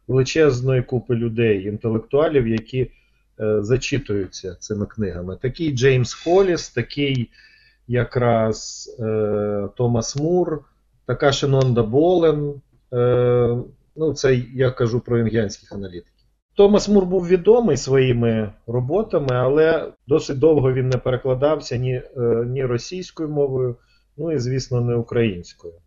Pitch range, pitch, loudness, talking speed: 115-145 Hz, 125 Hz, -20 LUFS, 115 wpm